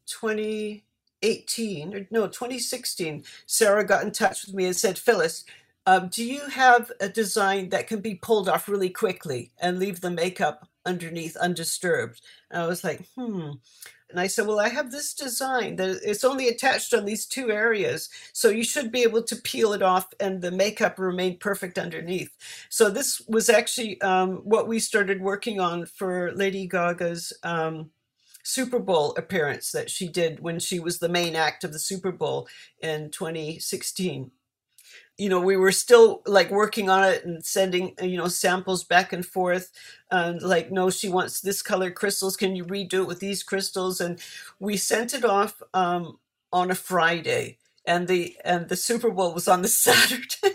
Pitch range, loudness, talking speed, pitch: 180-220 Hz, -24 LUFS, 180 wpm, 190 Hz